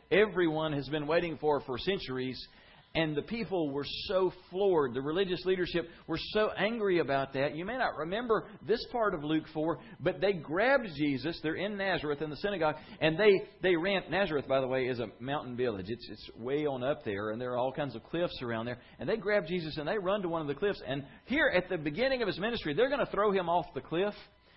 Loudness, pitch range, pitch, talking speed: -32 LUFS, 145-195 Hz, 165 Hz, 230 wpm